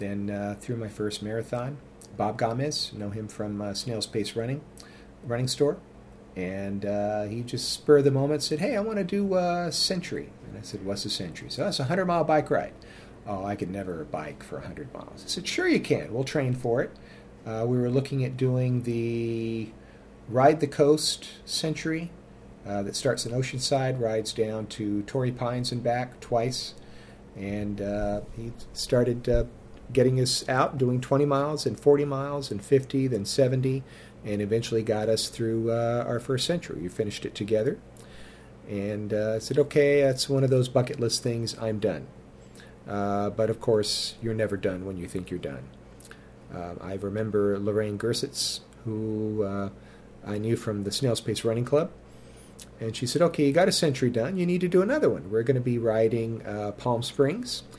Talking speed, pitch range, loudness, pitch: 190 wpm, 105-135 Hz, -27 LUFS, 115 Hz